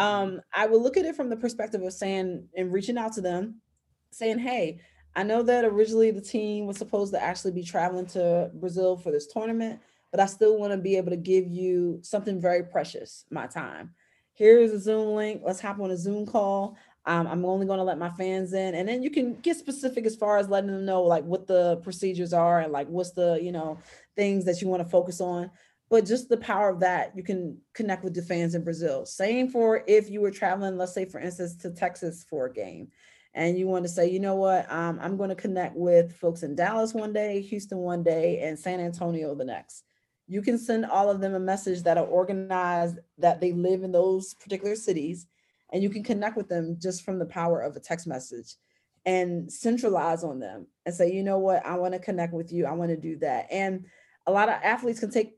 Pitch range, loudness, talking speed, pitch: 175-210 Hz, -27 LUFS, 235 wpm, 190 Hz